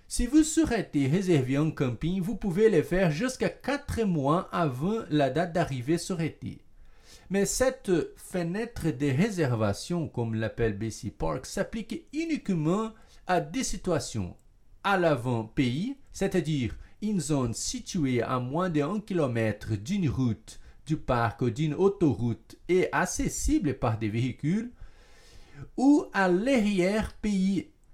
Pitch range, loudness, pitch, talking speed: 130-205 Hz, -28 LUFS, 170 Hz, 125 wpm